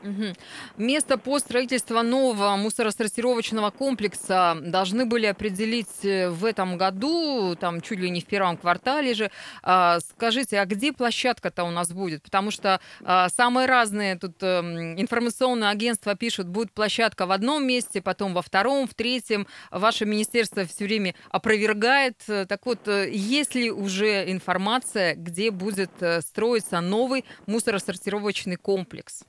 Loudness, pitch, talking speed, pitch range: -24 LUFS, 210 Hz, 130 wpm, 190-235 Hz